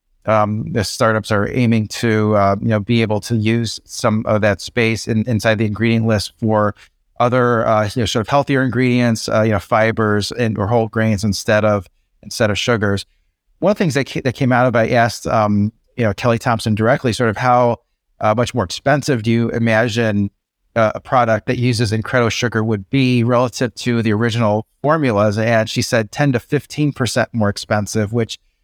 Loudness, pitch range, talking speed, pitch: -17 LUFS, 105-120 Hz, 205 wpm, 115 Hz